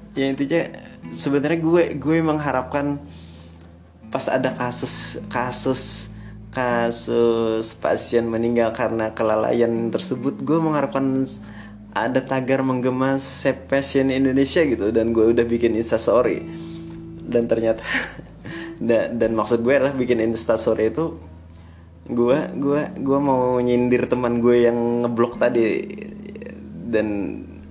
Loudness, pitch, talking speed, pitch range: -21 LUFS, 120 Hz, 110 wpm, 110-135 Hz